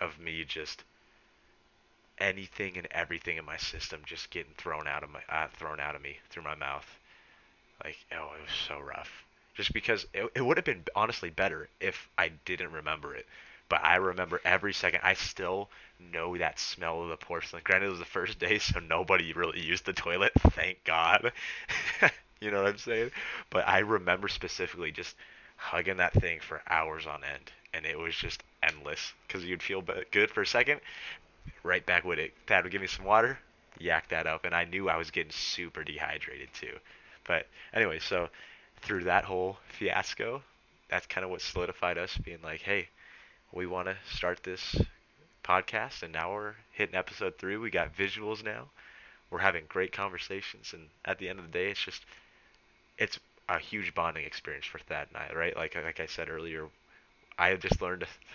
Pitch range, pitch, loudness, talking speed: 80-105 Hz, 95 Hz, -32 LUFS, 190 wpm